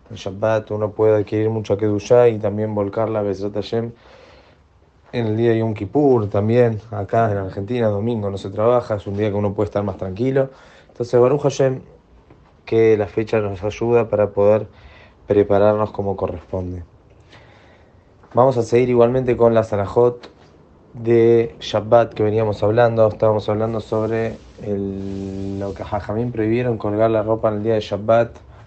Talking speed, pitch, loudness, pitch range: 155 wpm, 105 Hz, -19 LUFS, 100-115 Hz